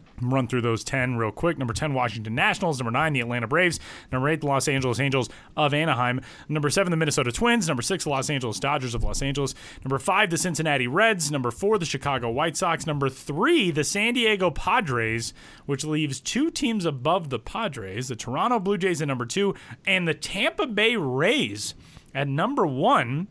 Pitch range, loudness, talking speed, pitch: 125-165 Hz, -24 LUFS, 195 wpm, 140 Hz